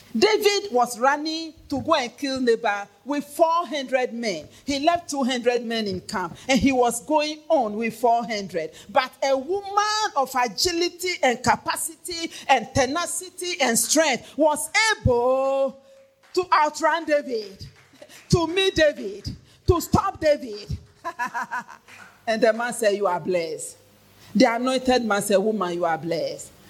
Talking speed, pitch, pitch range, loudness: 135 wpm, 270 Hz, 230-325 Hz, -23 LUFS